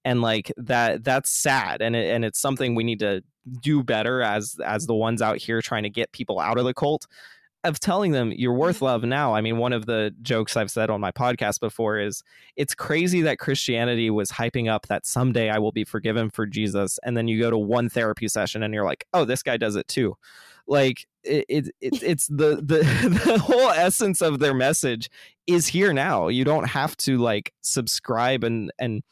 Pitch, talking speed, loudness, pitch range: 120 Hz, 215 wpm, -23 LUFS, 110-135 Hz